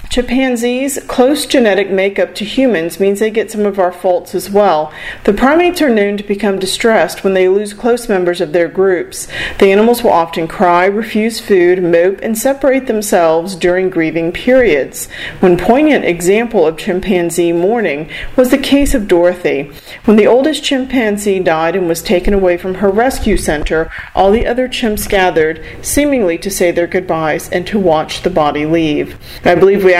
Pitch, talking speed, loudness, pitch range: 195 Hz, 175 wpm, -12 LUFS, 175-230 Hz